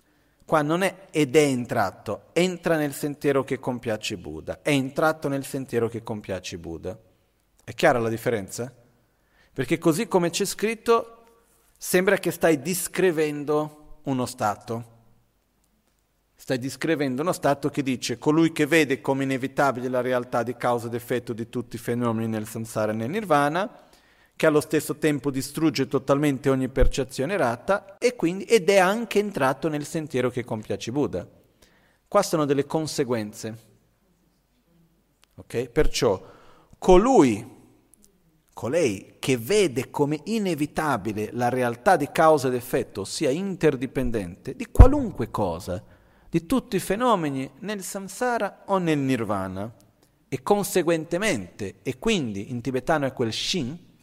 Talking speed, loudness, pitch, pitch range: 130 wpm, -24 LUFS, 145 Hz, 120-170 Hz